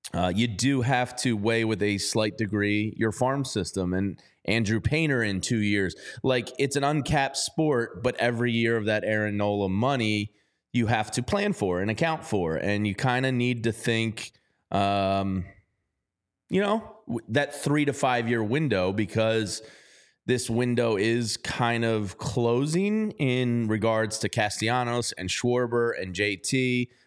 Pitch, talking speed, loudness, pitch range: 115 Hz, 155 wpm, -26 LUFS, 105-125 Hz